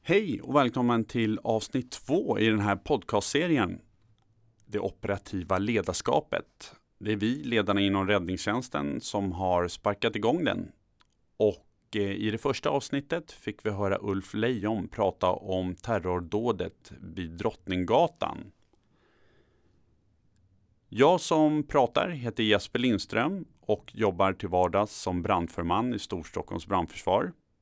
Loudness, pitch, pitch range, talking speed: -29 LUFS, 105 Hz, 95-115 Hz, 115 wpm